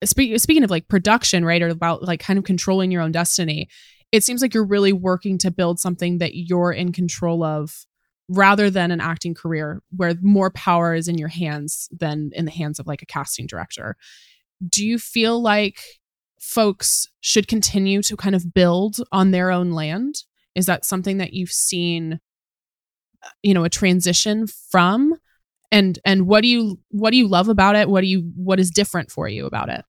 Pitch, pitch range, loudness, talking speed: 185 Hz, 170-205 Hz, -19 LUFS, 195 wpm